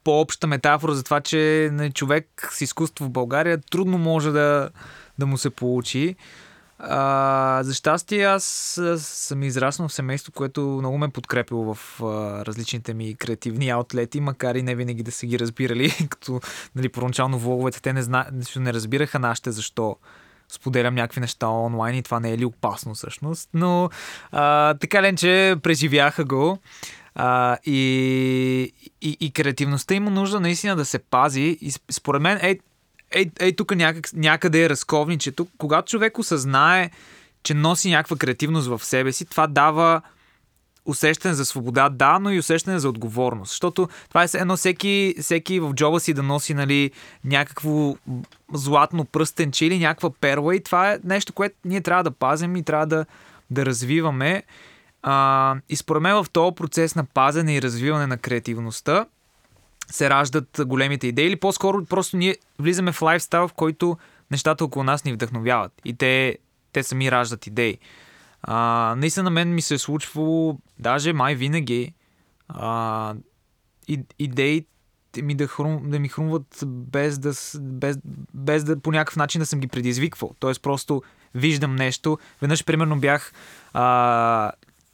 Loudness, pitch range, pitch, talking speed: -22 LUFS, 130-160 Hz, 145 Hz, 160 wpm